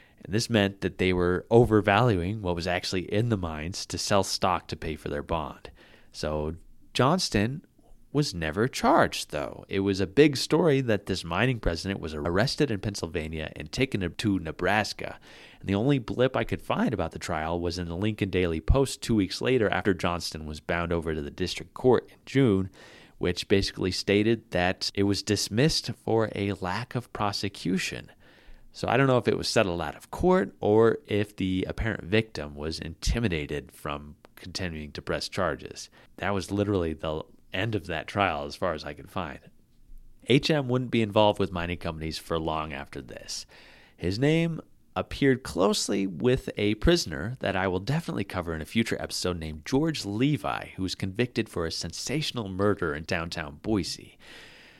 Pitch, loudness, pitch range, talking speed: 100 Hz, -27 LUFS, 85-115 Hz, 180 wpm